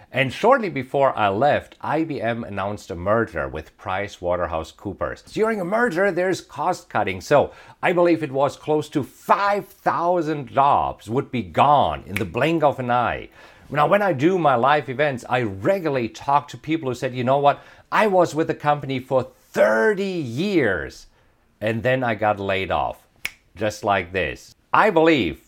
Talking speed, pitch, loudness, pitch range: 170 wpm, 135 Hz, -21 LUFS, 115-160 Hz